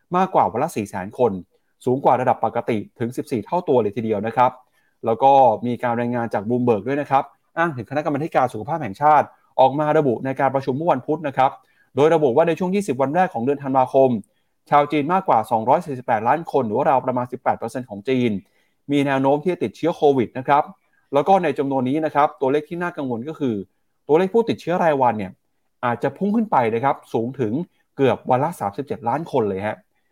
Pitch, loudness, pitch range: 135 Hz, -20 LUFS, 125-155 Hz